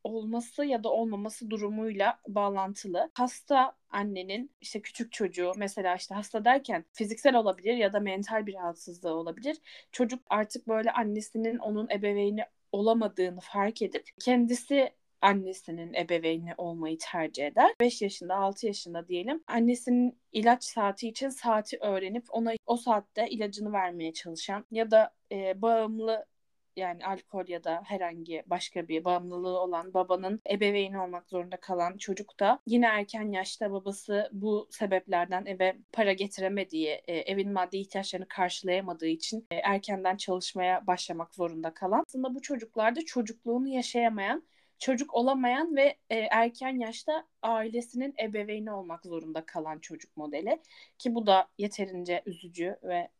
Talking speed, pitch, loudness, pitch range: 130 wpm, 205 Hz, -31 LUFS, 185-235 Hz